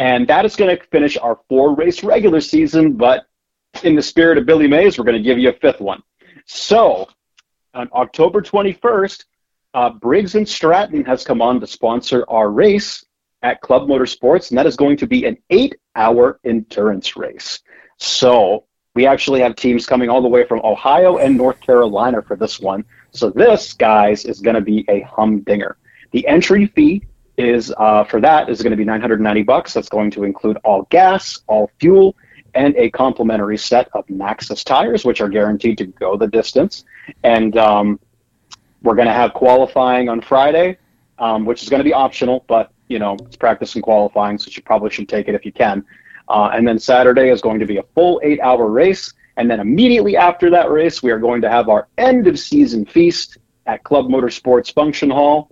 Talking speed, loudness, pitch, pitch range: 195 wpm, -14 LUFS, 125 Hz, 115-170 Hz